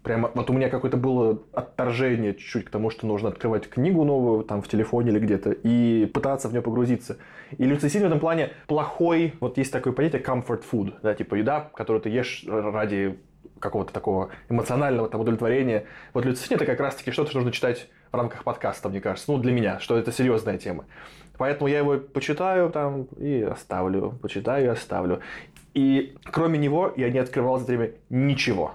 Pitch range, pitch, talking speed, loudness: 110-140 Hz, 125 Hz, 190 wpm, -25 LUFS